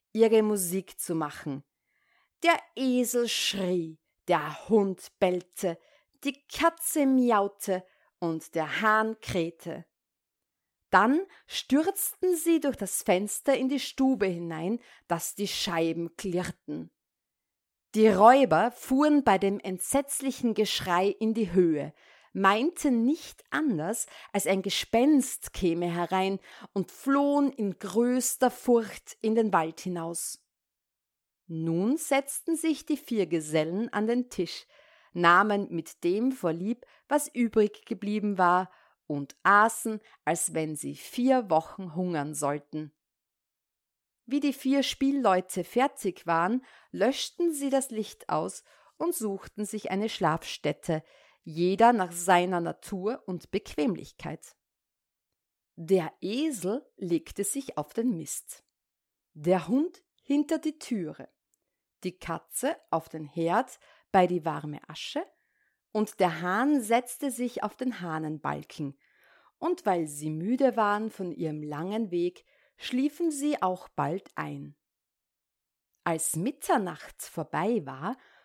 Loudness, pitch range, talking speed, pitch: -28 LUFS, 170-255 Hz, 115 wpm, 200 Hz